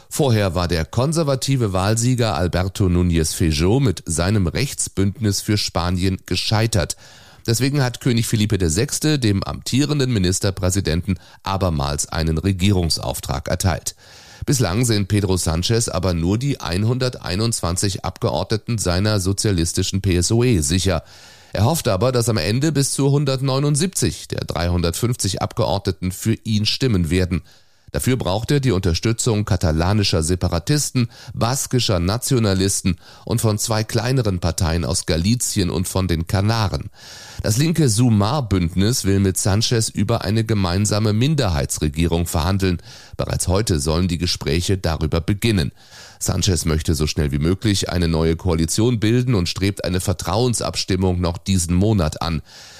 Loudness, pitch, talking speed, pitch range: -19 LUFS, 100 Hz, 125 wpm, 90-115 Hz